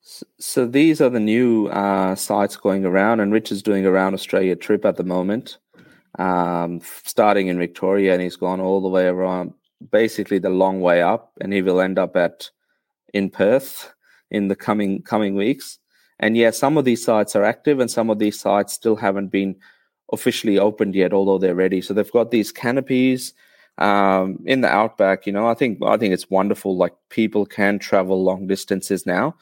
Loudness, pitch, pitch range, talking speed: -19 LUFS, 100 Hz, 95-105 Hz, 195 wpm